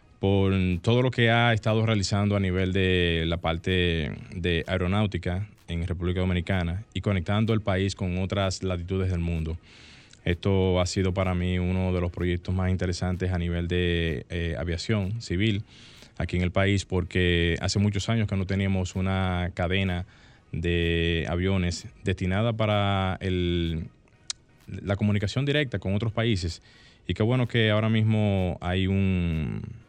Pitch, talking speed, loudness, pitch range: 95 Hz, 150 wpm, -26 LUFS, 90-105 Hz